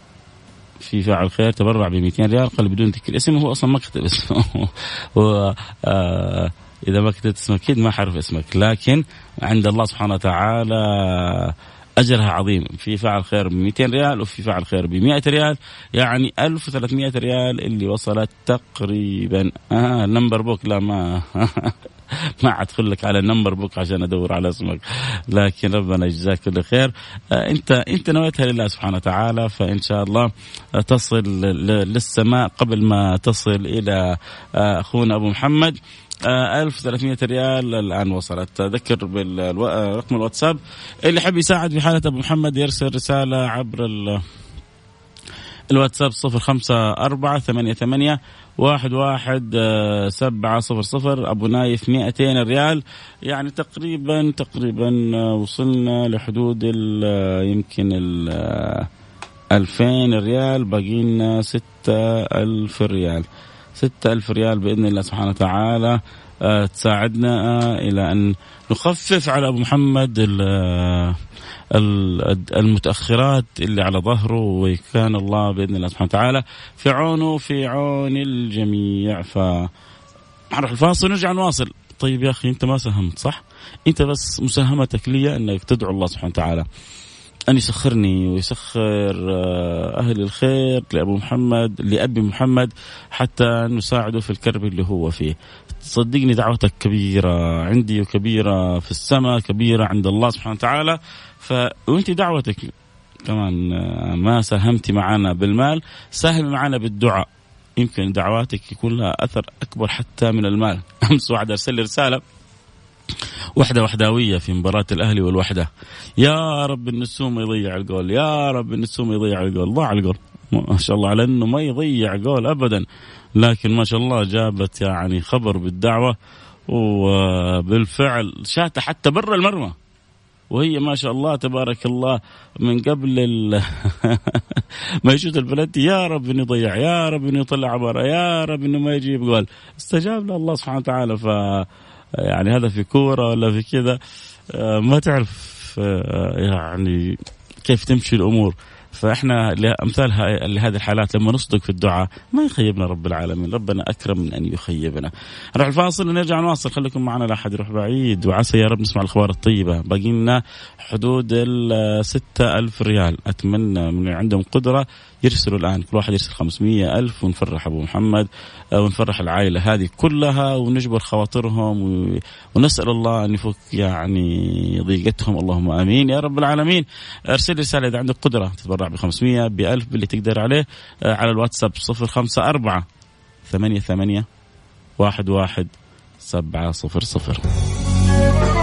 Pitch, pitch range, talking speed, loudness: 110 Hz, 100-125 Hz, 130 wpm, -19 LUFS